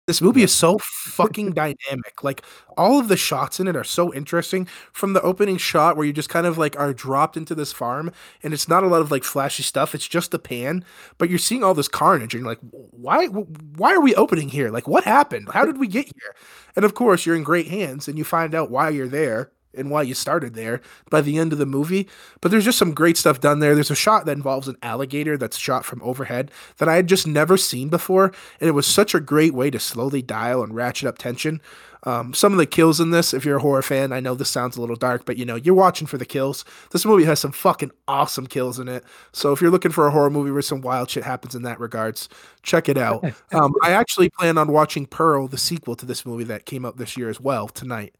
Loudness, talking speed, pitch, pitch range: -20 LUFS, 260 wpm, 150 Hz, 130-170 Hz